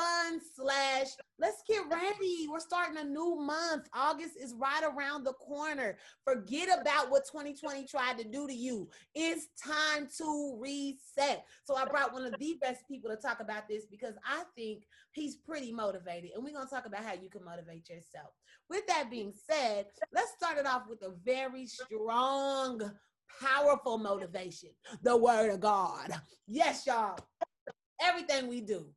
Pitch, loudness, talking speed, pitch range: 270 Hz, -35 LUFS, 165 wpm, 230-305 Hz